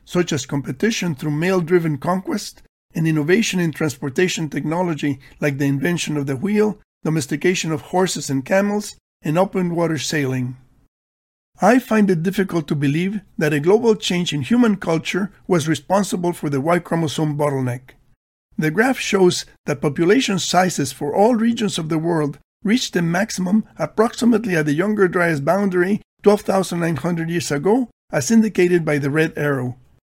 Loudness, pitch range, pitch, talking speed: -19 LUFS, 150-195 Hz, 170 Hz, 155 wpm